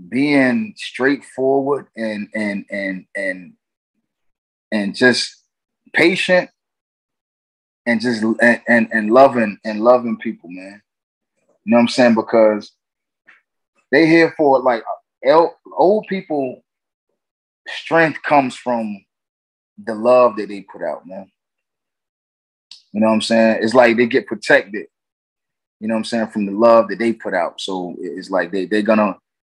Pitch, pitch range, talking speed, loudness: 115 Hz, 105-125 Hz, 140 wpm, -16 LUFS